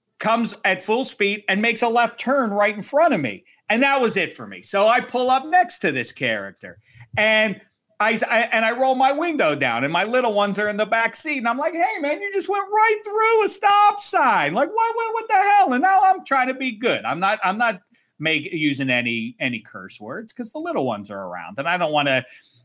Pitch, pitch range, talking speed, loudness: 235 Hz, 205-335 Hz, 245 wpm, -20 LUFS